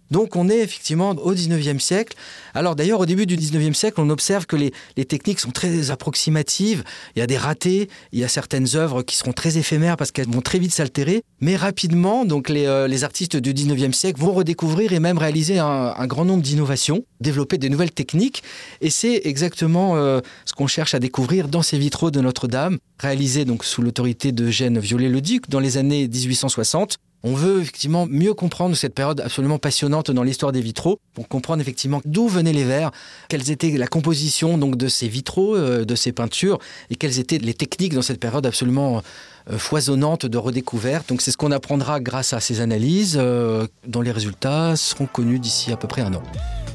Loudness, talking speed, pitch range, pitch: -20 LUFS, 200 wpm, 130-170 Hz, 145 Hz